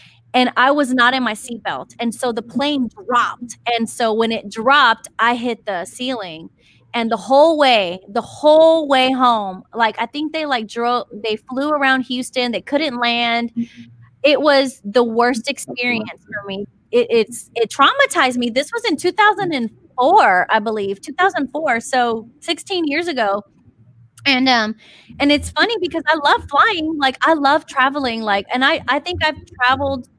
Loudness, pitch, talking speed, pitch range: -17 LUFS, 250 Hz, 170 wpm, 230-285 Hz